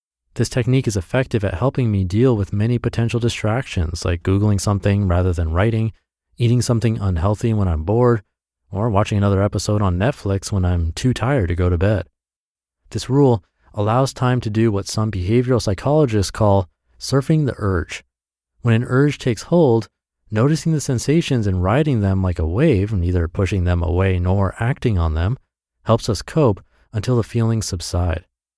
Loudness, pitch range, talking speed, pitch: -19 LUFS, 90-120 Hz, 170 wpm, 105 Hz